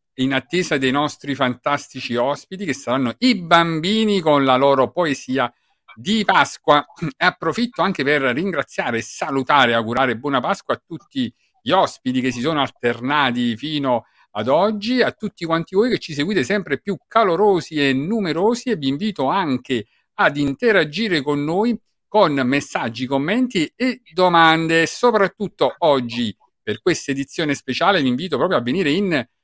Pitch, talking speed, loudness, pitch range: 160 Hz, 150 wpm, -19 LUFS, 135-205 Hz